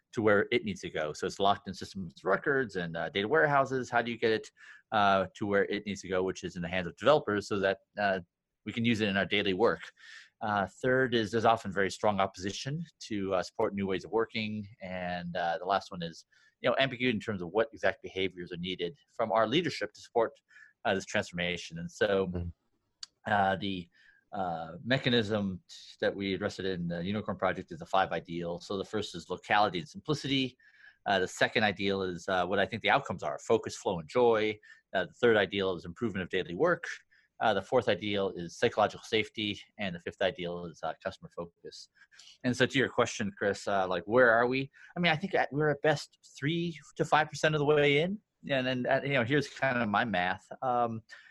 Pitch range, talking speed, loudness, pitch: 95-130 Hz, 220 wpm, -31 LUFS, 105 Hz